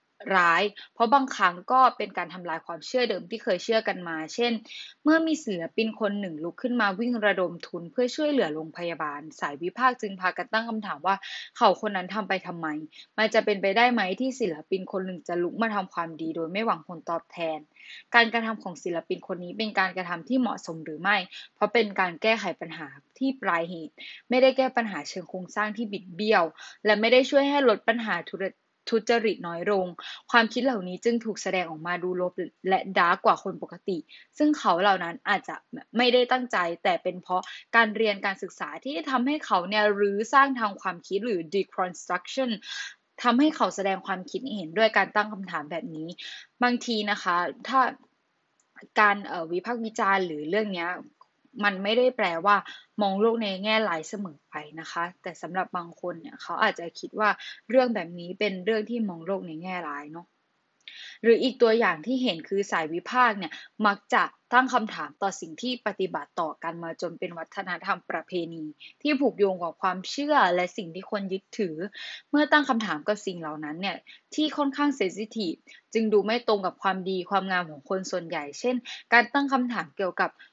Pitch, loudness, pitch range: 205 Hz, -26 LUFS, 180-240 Hz